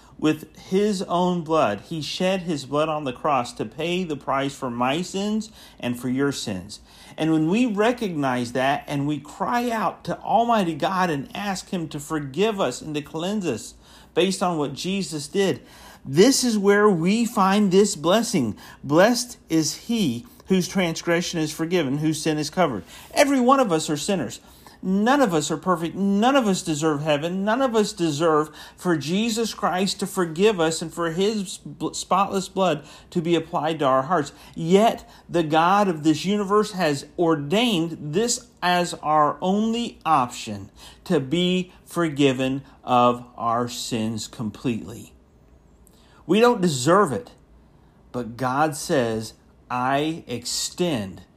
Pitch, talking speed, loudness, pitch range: 165 Hz, 155 wpm, -23 LUFS, 145-195 Hz